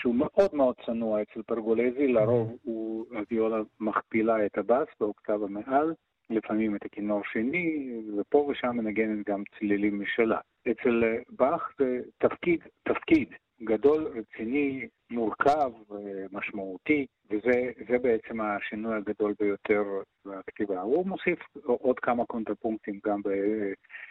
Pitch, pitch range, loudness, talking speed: 110 Hz, 105-125 Hz, -29 LUFS, 115 wpm